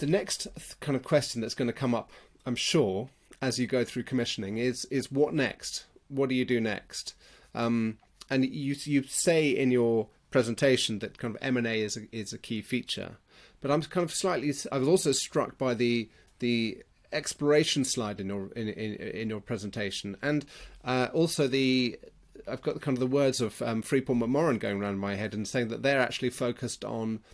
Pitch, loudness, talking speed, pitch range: 125 Hz, -29 LUFS, 200 wpm, 110-135 Hz